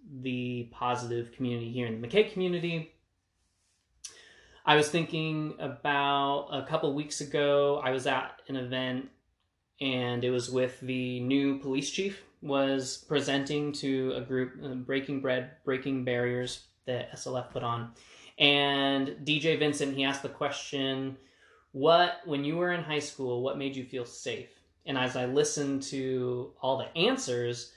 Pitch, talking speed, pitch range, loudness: 135 Hz, 155 wpm, 125-145 Hz, -30 LUFS